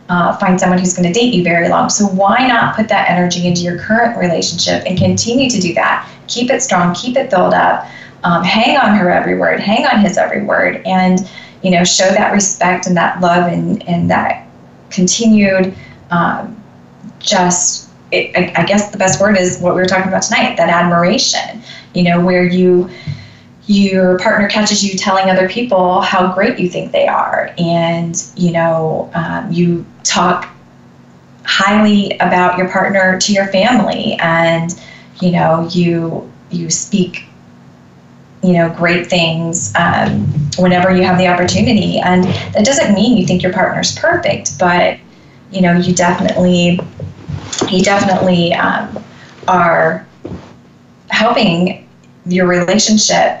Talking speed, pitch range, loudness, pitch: 155 wpm, 175-200 Hz, -12 LUFS, 185 Hz